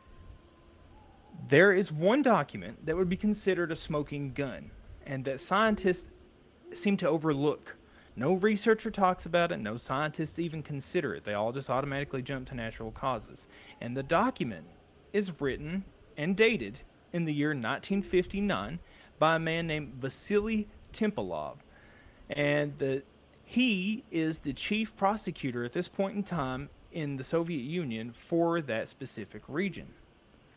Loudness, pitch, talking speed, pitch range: -31 LUFS, 160 Hz, 140 wpm, 135-190 Hz